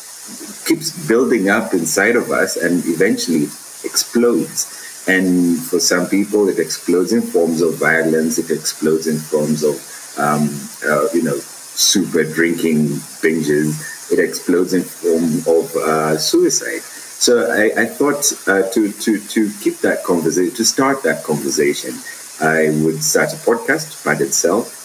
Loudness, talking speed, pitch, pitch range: -16 LUFS, 145 wpm, 80 Hz, 80-110 Hz